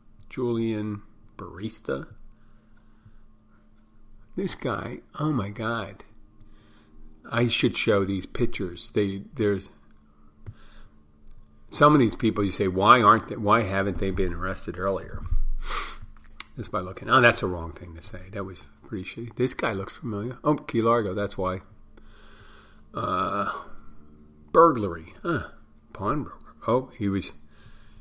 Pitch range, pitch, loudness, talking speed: 90-110 Hz, 105 Hz, -26 LUFS, 125 wpm